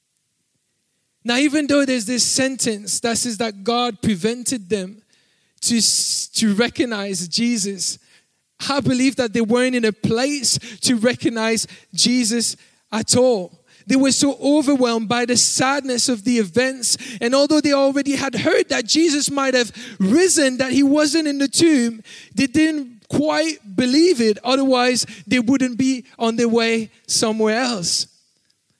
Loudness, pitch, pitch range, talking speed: -18 LUFS, 245 Hz, 225-275 Hz, 145 wpm